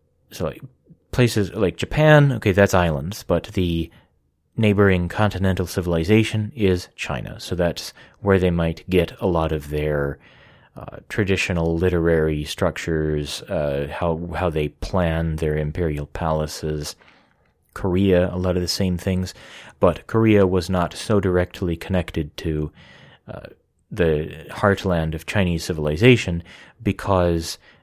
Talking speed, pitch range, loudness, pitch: 125 wpm, 80-95 Hz, -21 LUFS, 90 Hz